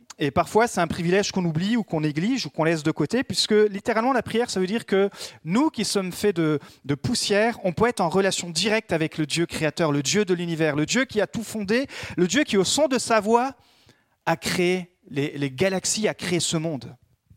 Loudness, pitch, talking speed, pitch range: -23 LUFS, 190 Hz, 230 wpm, 165-220 Hz